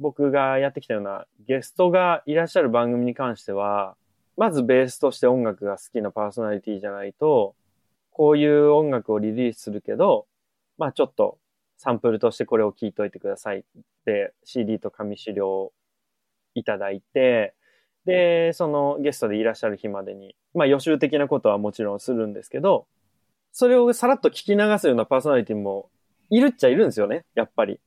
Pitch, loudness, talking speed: 135 Hz, -22 LUFS, 390 characters per minute